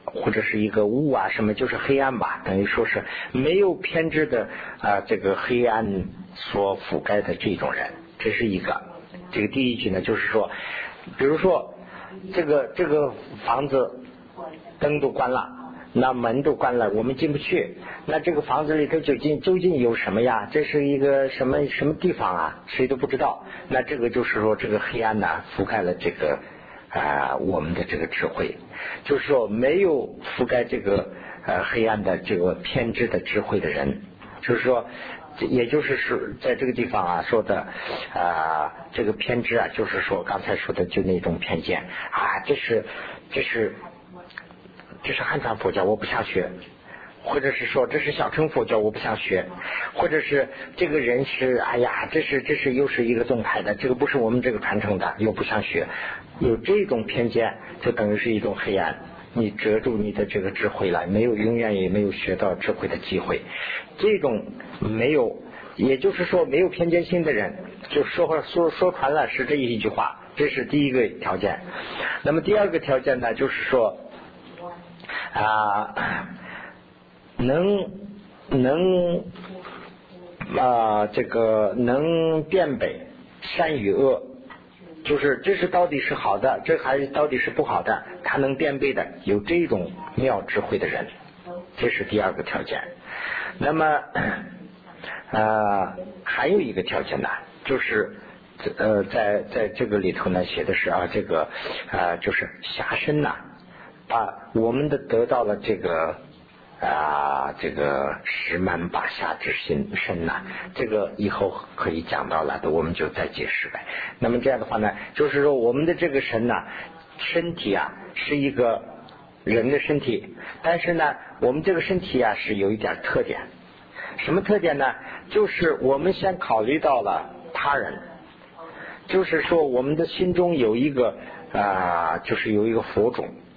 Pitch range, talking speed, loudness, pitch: 110-175 Hz, 240 characters per minute, -24 LUFS, 140 Hz